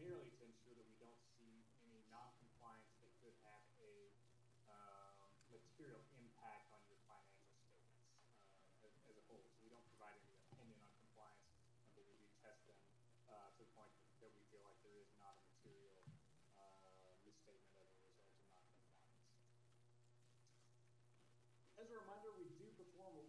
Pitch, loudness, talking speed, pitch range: 120 Hz, -65 LUFS, 175 wpm, 110-120 Hz